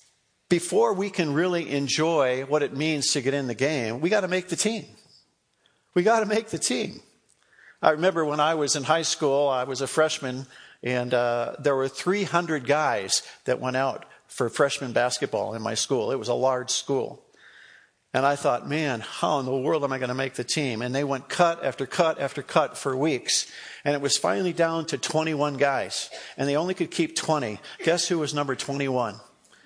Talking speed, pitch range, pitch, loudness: 200 wpm, 130-165 Hz, 145 Hz, -25 LUFS